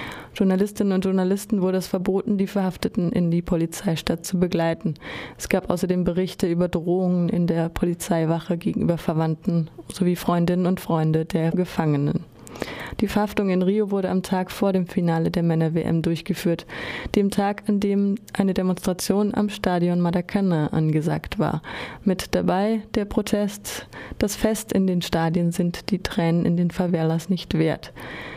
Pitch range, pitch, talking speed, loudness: 170-200 Hz, 180 Hz, 150 wpm, -23 LUFS